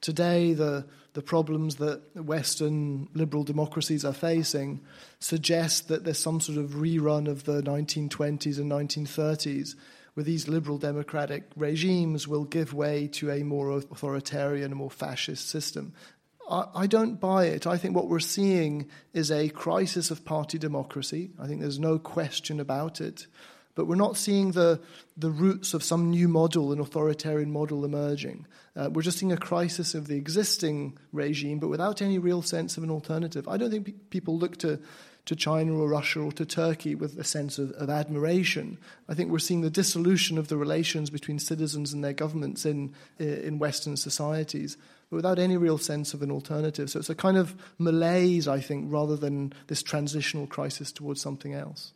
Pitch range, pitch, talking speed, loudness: 145-165 Hz, 155 Hz, 180 wpm, -28 LUFS